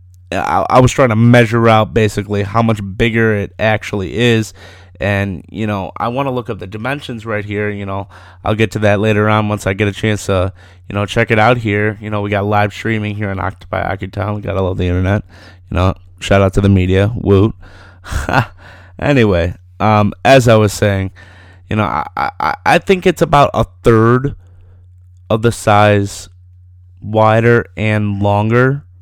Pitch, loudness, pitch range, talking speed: 105 Hz, -14 LUFS, 95-110 Hz, 190 wpm